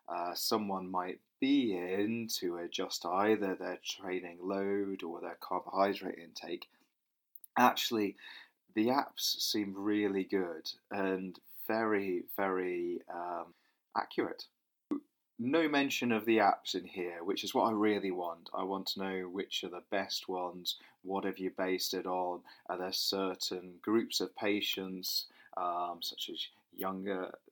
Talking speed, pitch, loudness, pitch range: 140 wpm, 95 Hz, -35 LUFS, 90-105 Hz